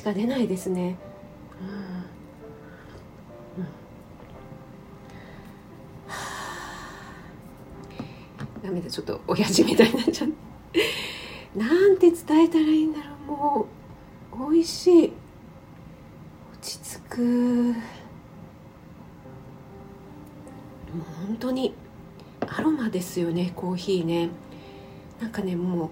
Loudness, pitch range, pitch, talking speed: -25 LUFS, 180-305 Hz, 230 Hz, 180 characters per minute